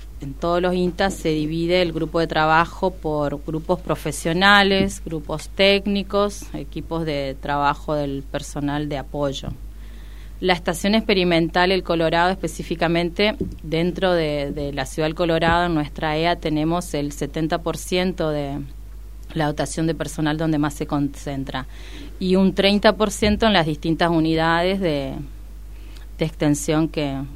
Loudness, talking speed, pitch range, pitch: -21 LUFS, 135 wpm, 150-180 Hz, 160 Hz